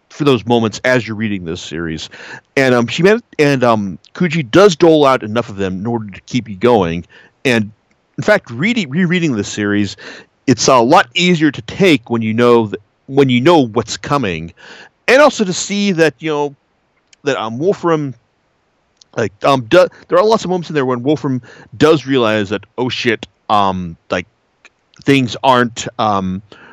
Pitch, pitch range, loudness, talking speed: 130 Hz, 110-160 Hz, -14 LUFS, 180 wpm